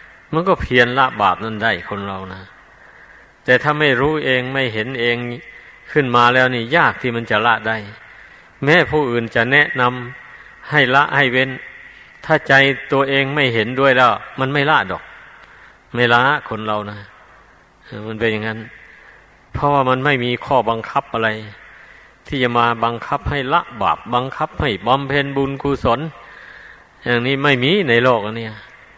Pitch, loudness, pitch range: 125 Hz, -16 LUFS, 110-140 Hz